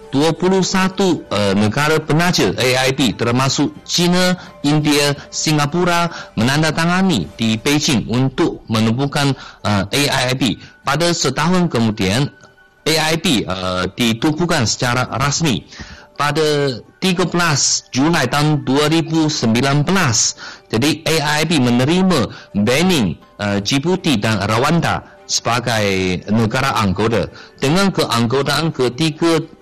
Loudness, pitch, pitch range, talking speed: -16 LUFS, 145 Hz, 115-165 Hz, 85 wpm